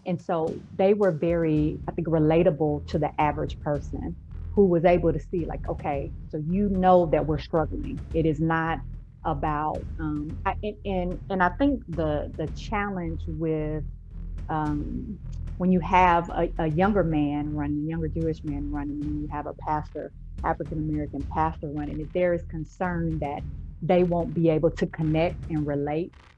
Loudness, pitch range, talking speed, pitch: -26 LUFS, 150-175 Hz, 170 wpm, 160 Hz